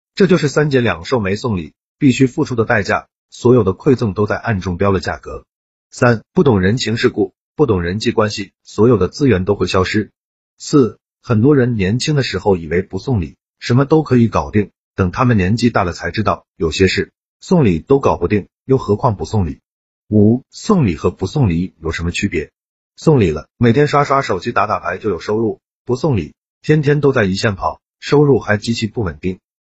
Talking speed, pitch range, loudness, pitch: 290 characters per minute, 95-130 Hz, -16 LUFS, 110 Hz